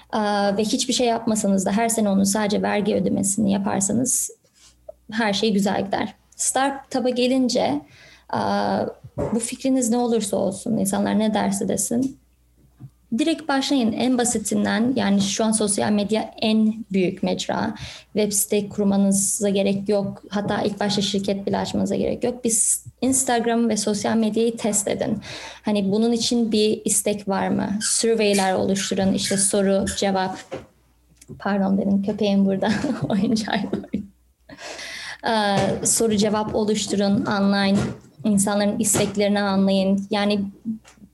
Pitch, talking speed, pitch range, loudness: 210 Hz, 125 wpm, 200-230 Hz, -21 LUFS